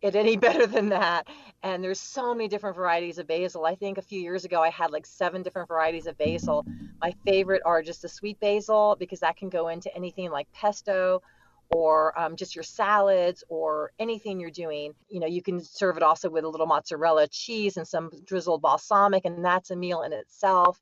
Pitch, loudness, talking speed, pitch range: 180 Hz, -26 LUFS, 210 wpm, 165-200 Hz